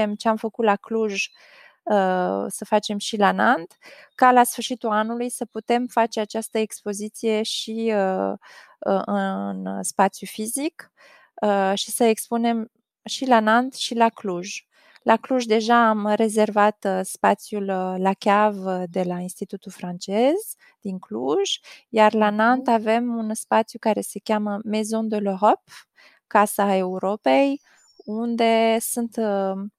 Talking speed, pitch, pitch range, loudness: 135 wpm, 215 Hz, 195-230 Hz, -22 LUFS